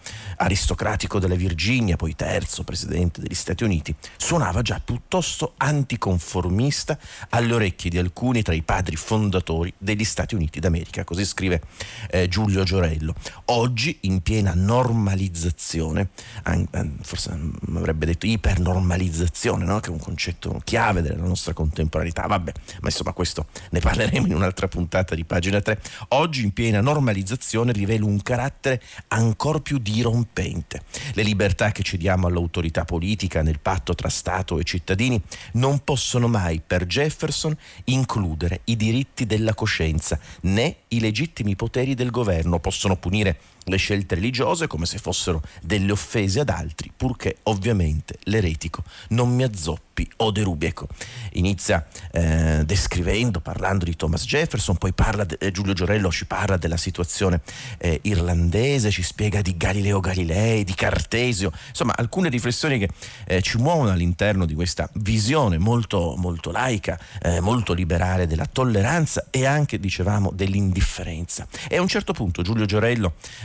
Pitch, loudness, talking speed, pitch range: 95 Hz, -23 LUFS, 140 wpm, 90-110 Hz